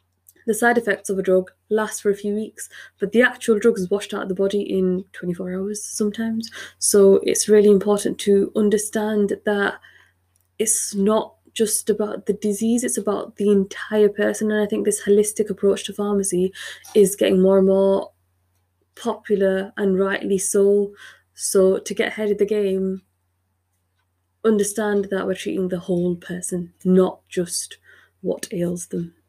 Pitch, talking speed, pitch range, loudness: 200 Hz, 160 wpm, 185-210 Hz, -20 LUFS